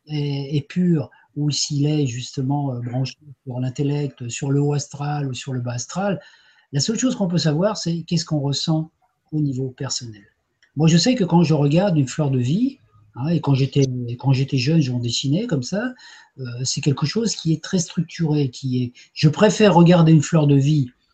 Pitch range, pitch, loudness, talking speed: 135-165 Hz, 145 Hz, -20 LUFS, 200 wpm